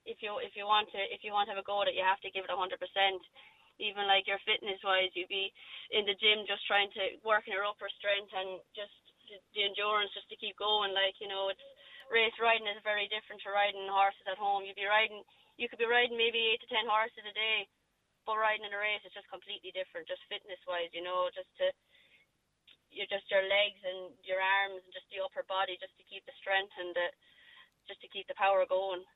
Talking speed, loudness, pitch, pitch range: 245 wpm, -33 LUFS, 200 Hz, 190-215 Hz